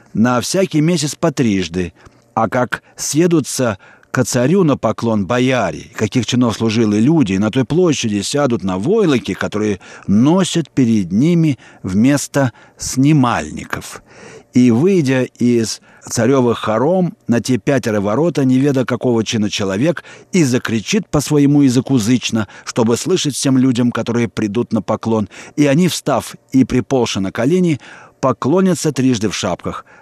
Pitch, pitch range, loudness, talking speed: 125 Hz, 110-145 Hz, -16 LUFS, 140 wpm